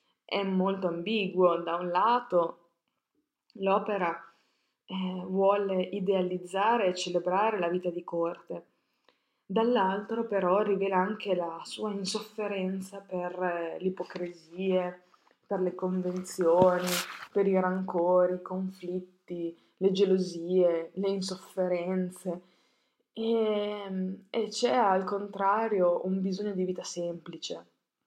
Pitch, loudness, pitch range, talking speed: 185 Hz, -30 LUFS, 180-200 Hz, 105 wpm